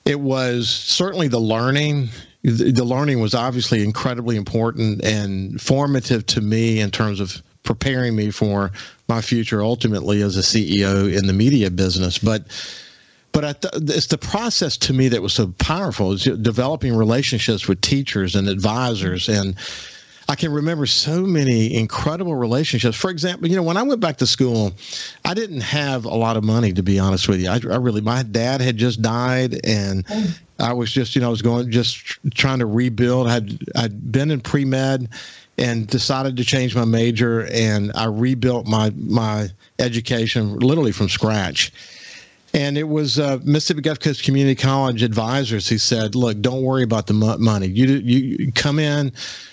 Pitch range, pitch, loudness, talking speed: 110-135 Hz, 120 Hz, -19 LUFS, 175 wpm